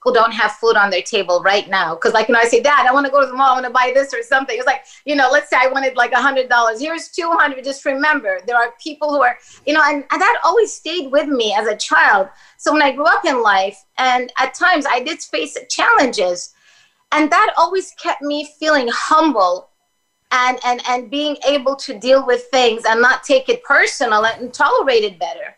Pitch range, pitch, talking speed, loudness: 240-310 Hz, 270 Hz, 240 wpm, -15 LUFS